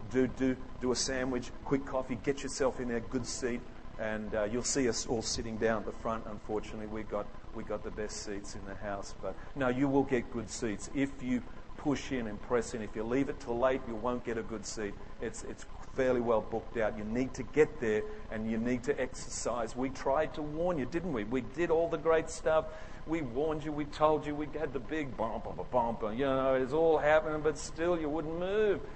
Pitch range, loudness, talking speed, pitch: 110-150 Hz, -34 LUFS, 235 wpm, 125 Hz